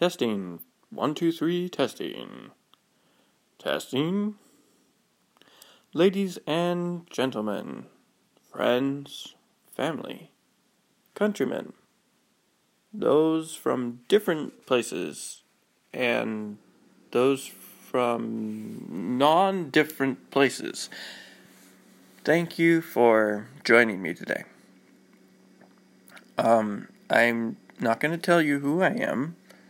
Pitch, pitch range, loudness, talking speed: 145 Hz, 120-175 Hz, -26 LUFS, 75 wpm